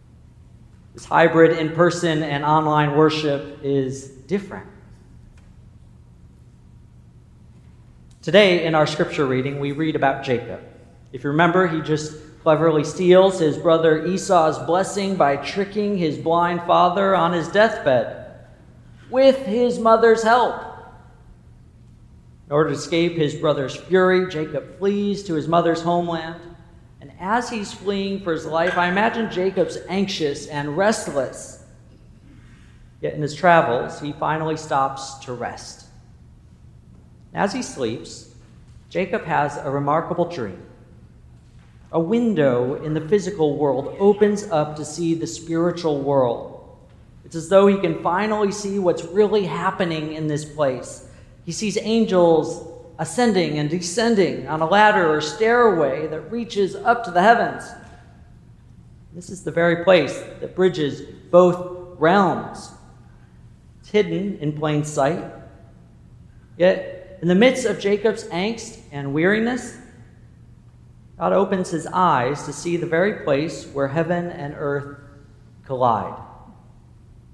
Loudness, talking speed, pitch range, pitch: -20 LUFS, 125 wpm, 145-190 Hz, 165 Hz